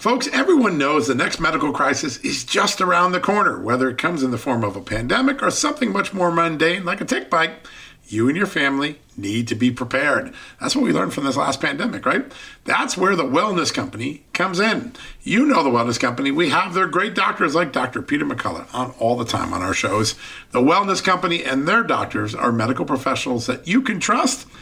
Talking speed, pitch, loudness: 215 wpm, 180 Hz, -19 LUFS